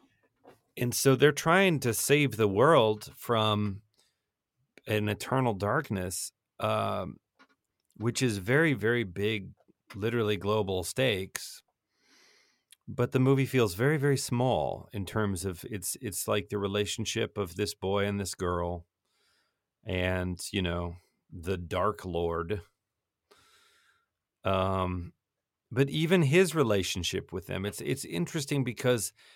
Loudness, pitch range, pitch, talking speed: -29 LUFS, 95-125 Hz, 105 Hz, 120 wpm